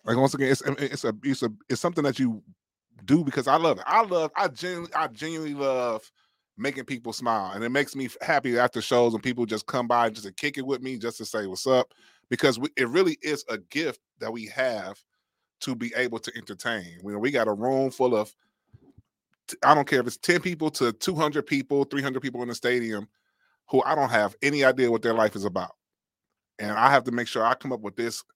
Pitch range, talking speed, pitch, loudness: 115-140 Hz, 235 wpm, 125 Hz, -26 LUFS